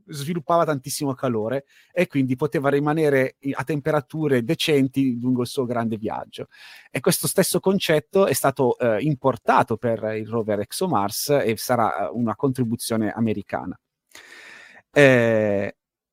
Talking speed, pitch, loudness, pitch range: 125 wpm, 135 Hz, -22 LUFS, 115-150 Hz